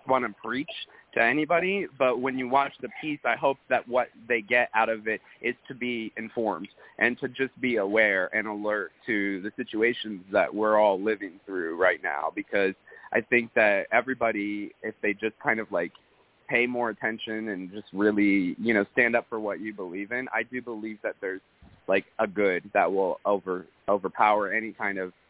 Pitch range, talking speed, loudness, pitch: 105-125 Hz, 195 wpm, -27 LUFS, 110 Hz